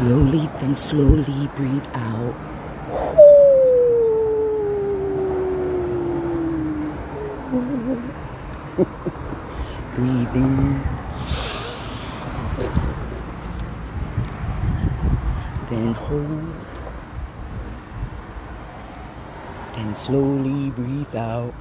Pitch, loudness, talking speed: 140 Hz, -21 LUFS, 35 wpm